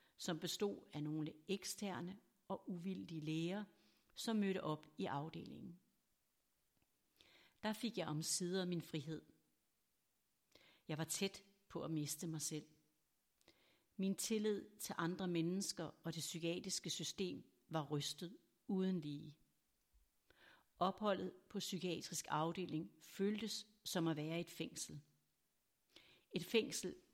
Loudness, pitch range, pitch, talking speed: -44 LUFS, 155-195 Hz, 175 Hz, 115 wpm